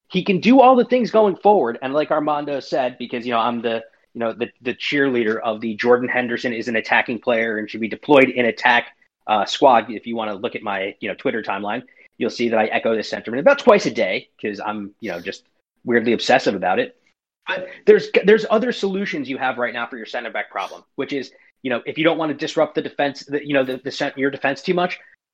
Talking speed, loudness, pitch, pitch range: 245 wpm, -19 LUFS, 130 Hz, 115-160 Hz